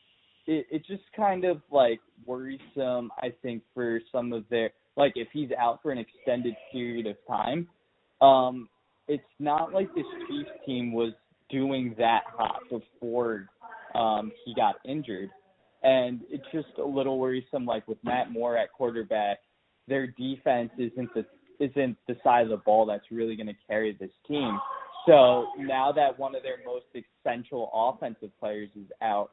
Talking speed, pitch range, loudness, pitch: 160 wpm, 115-145 Hz, -28 LUFS, 125 Hz